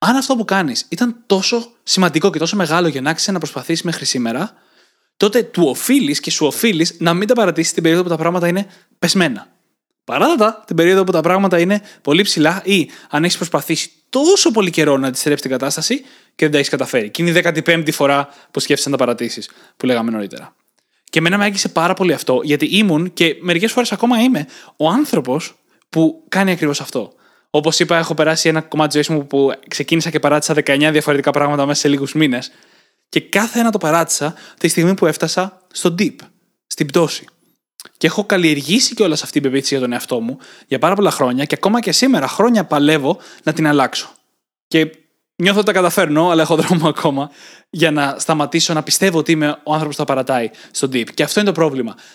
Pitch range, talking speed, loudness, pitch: 150-195 Hz, 205 wpm, -16 LUFS, 165 Hz